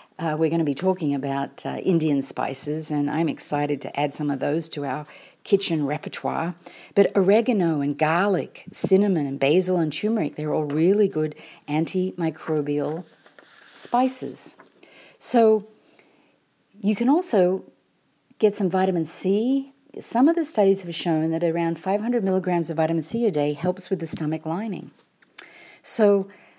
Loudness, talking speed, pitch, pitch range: -23 LUFS, 150 wpm, 170 Hz, 155-200 Hz